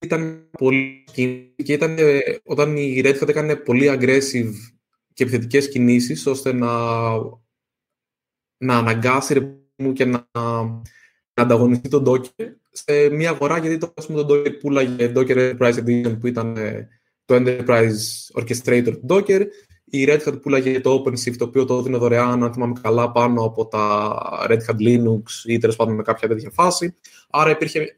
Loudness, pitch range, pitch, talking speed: -19 LUFS, 120-145 Hz, 125 Hz, 155 wpm